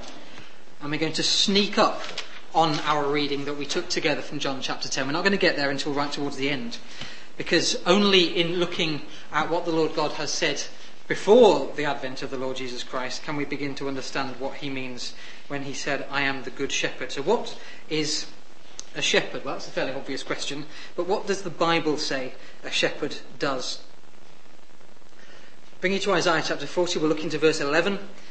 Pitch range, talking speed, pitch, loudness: 140-175 Hz, 200 wpm, 150 Hz, -25 LUFS